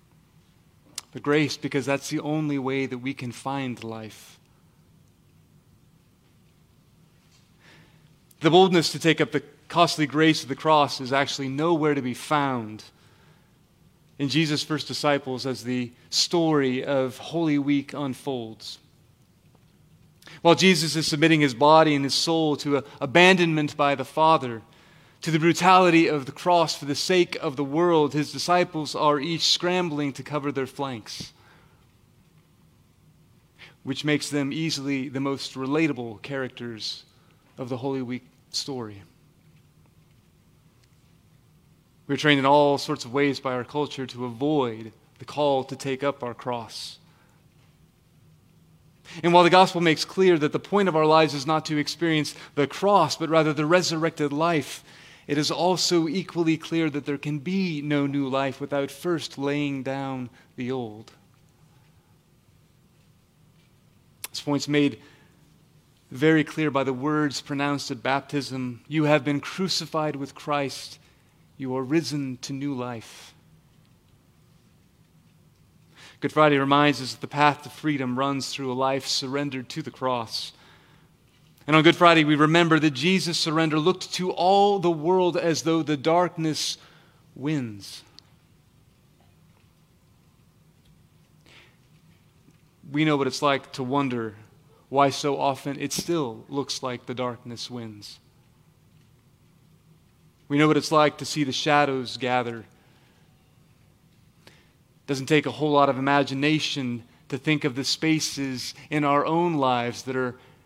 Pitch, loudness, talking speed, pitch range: 145 Hz, -24 LUFS, 140 wpm, 135-155 Hz